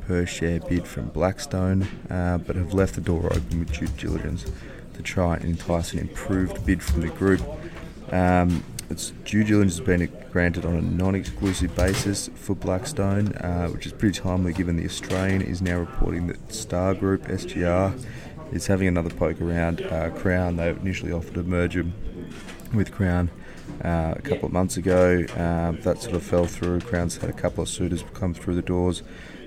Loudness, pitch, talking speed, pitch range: -25 LUFS, 90 Hz, 180 wpm, 85-95 Hz